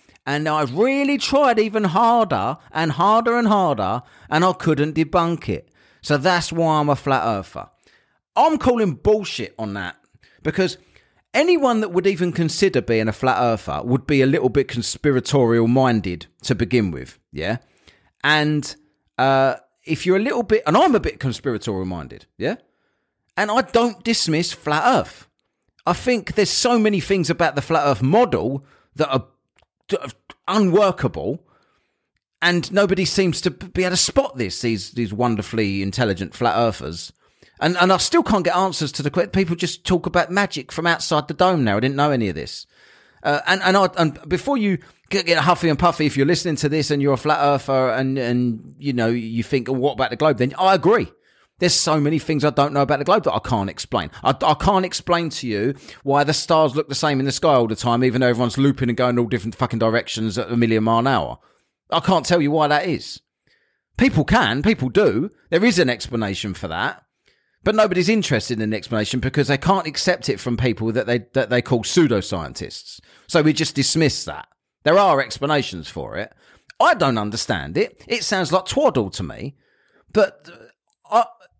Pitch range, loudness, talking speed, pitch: 125-180 Hz, -19 LUFS, 195 wpm, 150 Hz